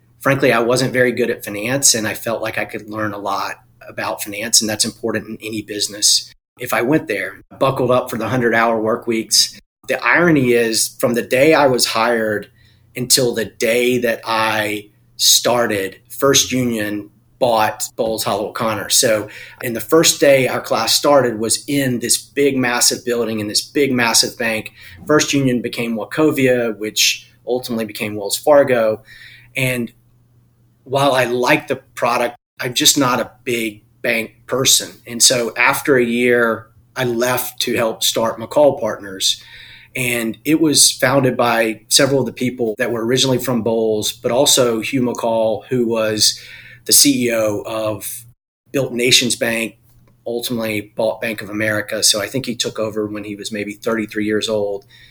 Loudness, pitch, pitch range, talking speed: -16 LUFS, 115 Hz, 110-125 Hz, 165 wpm